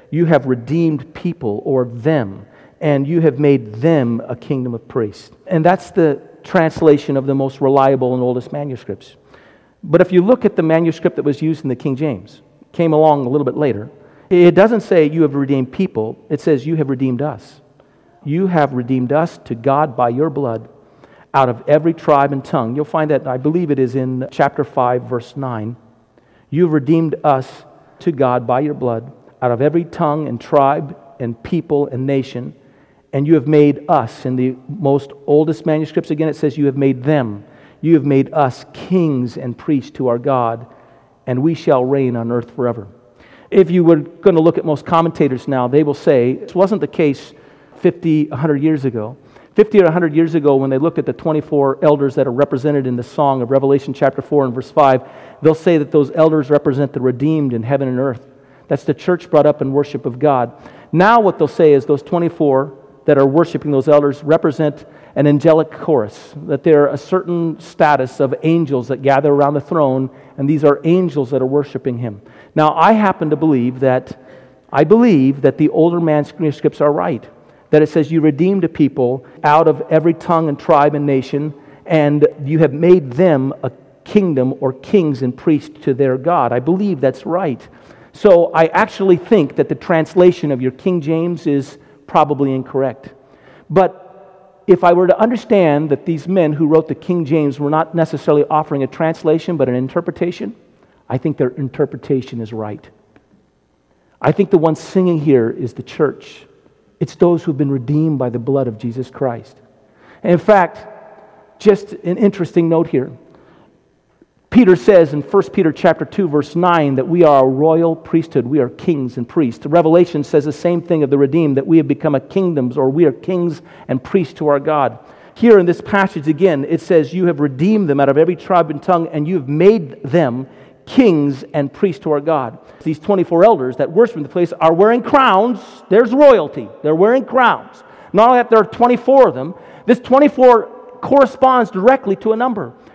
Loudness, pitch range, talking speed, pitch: -15 LUFS, 135-170 Hz, 195 wpm, 150 Hz